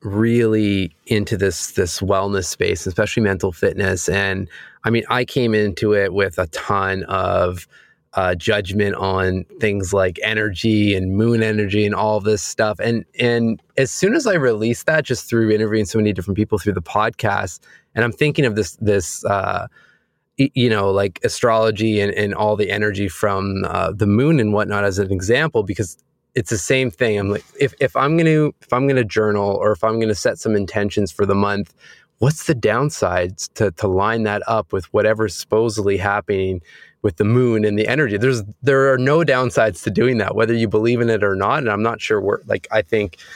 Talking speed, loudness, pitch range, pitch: 200 wpm, -18 LUFS, 100-115 Hz, 105 Hz